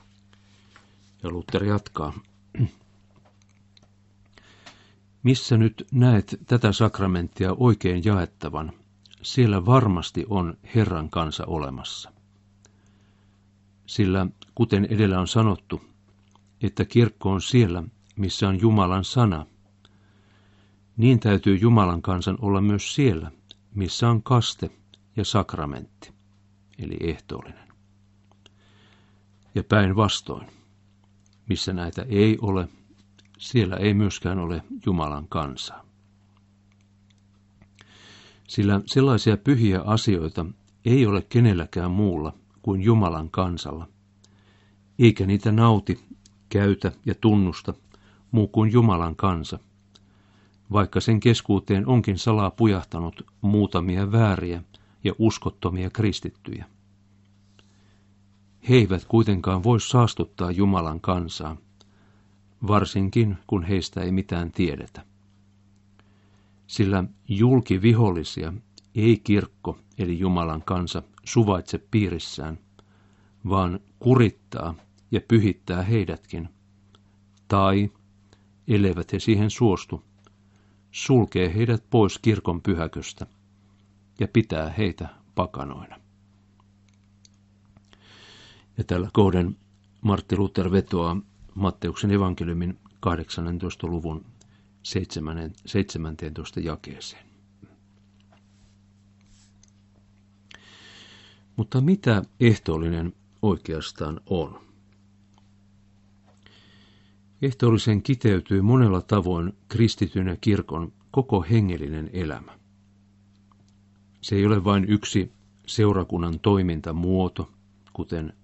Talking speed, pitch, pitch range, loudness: 85 wpm, 100 Hz, 95-105 Hz, -23 LUFS